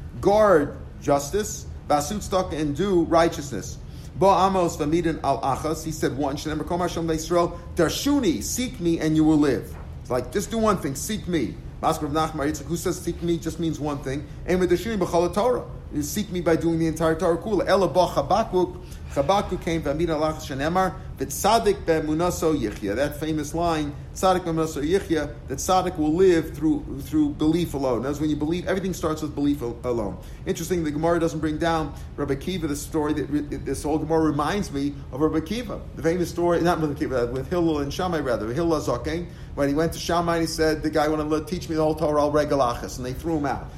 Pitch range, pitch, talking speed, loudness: 150-175 Hz, 160 Hz, 200 wpm, -24 LUFS